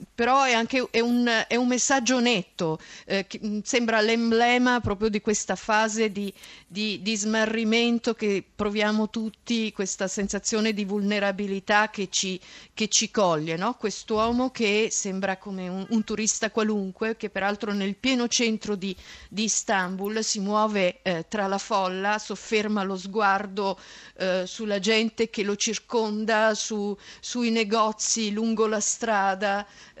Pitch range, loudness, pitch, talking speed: 200-225 Hz, -25 LUFS, 215 Hz, 145 wpm